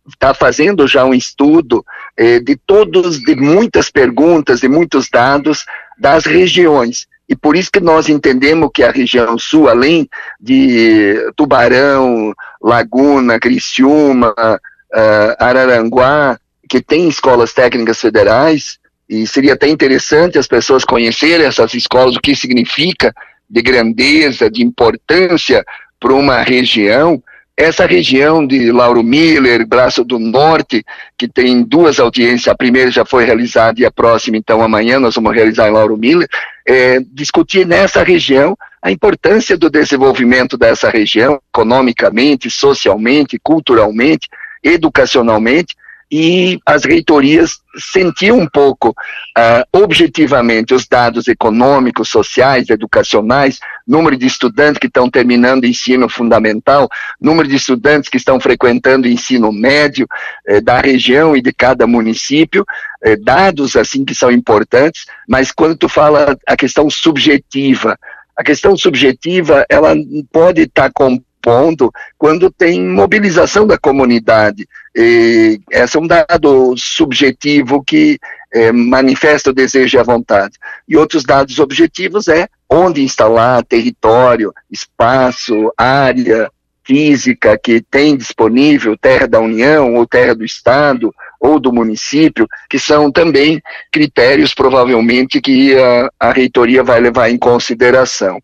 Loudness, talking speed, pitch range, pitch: -9 LUFS, 130 wpm, 120-180 Hz, 135 Hz